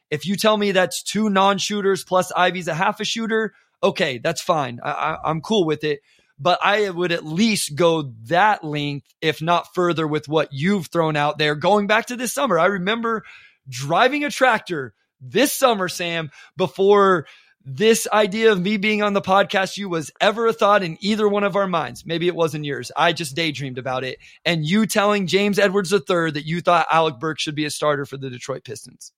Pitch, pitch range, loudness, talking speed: 180 Hz, 155-205 Hz, -20 LUFS, 210 wpm